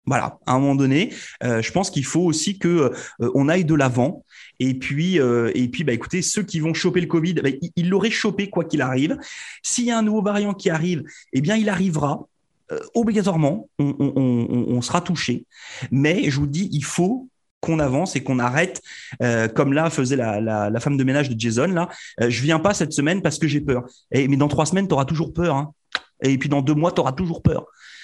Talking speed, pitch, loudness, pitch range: 240 wpm, 150 Hz, -21 LUFS, 135-175 Hz